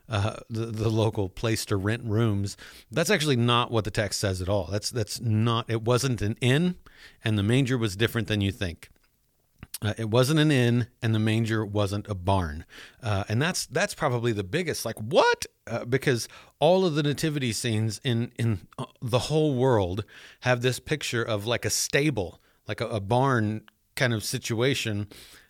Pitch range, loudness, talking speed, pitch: 105-130 Hz, -26 LUFS, 185 wpm, 115 Hz